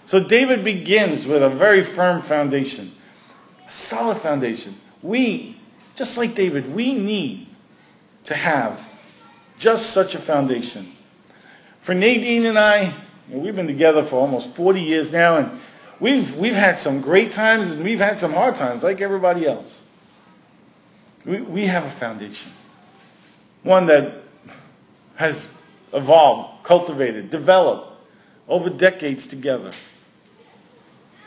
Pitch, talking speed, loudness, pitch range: 185 Hz, 125 wpm, -18 LUFS, 150-215 Hz